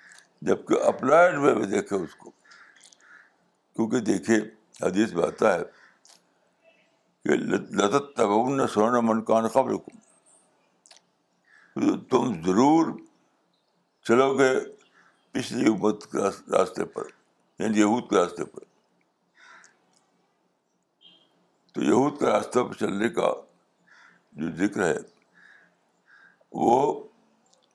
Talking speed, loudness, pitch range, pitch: 105 wpm, -24 LUFS, 105-135 Hz, 110 Hz